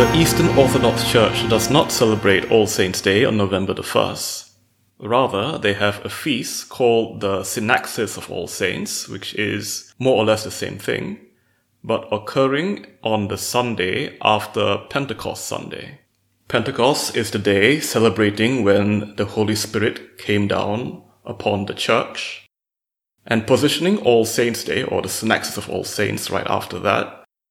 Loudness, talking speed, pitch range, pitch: -19 LUFS, 150 wpm, 100-120 Hz, 110 Hz